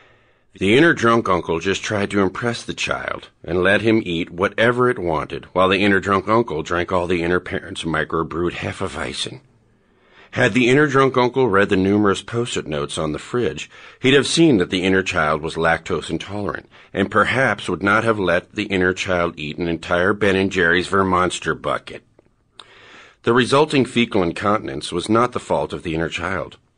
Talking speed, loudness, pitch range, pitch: 190 wpm, -19 LUFS, 85-115 Hz, 95 Hz